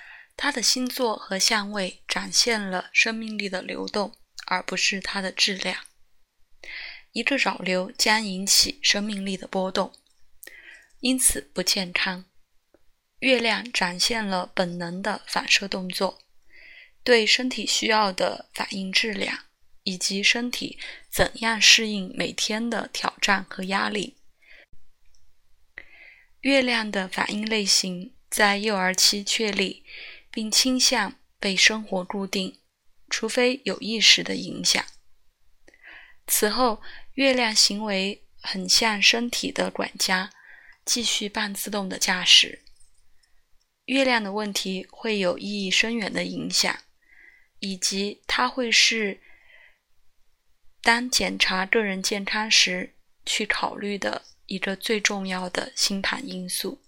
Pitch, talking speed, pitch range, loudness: 210 Hz, 180 characters per minute, 190-235 Hz, -22 LUFS